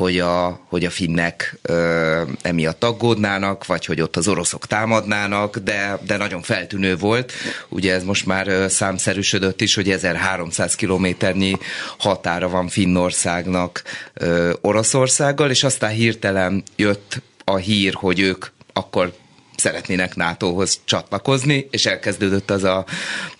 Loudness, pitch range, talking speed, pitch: -19 LUFS, 90-105 Hz, 125 wpm, 95 Hz